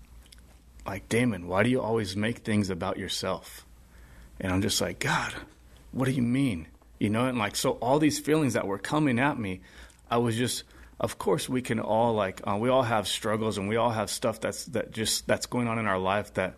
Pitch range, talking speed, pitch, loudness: 90-120 Hz, 220 wpm, 105 Hz, -28 LUFS